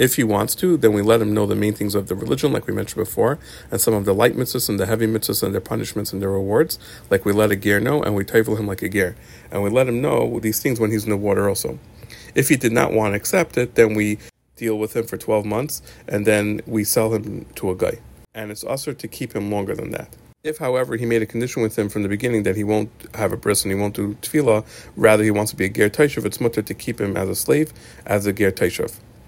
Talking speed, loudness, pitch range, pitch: 280 wpm, -20 LUFS, 105-120 Hz, 110 Hz